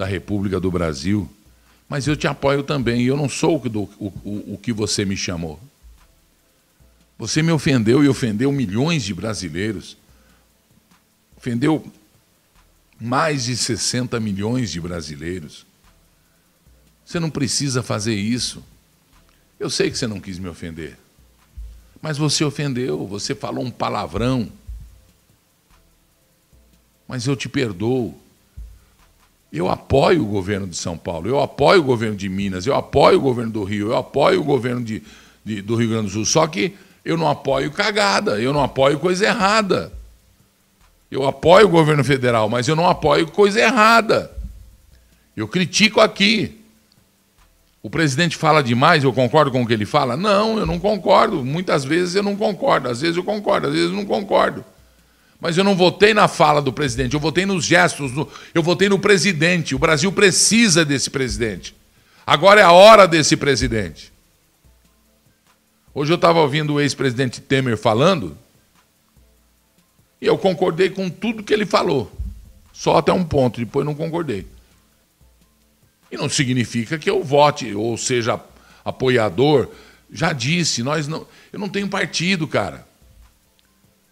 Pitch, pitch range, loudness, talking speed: 130 Hz, 105-165 Hz, -18 LUFS, 150 wpm